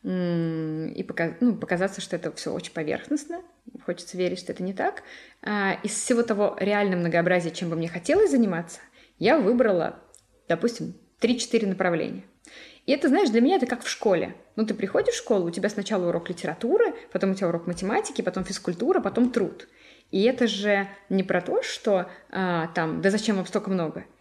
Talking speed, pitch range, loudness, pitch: 175 wpm, 180-230 Hz, -25 LUFS, 195 Hz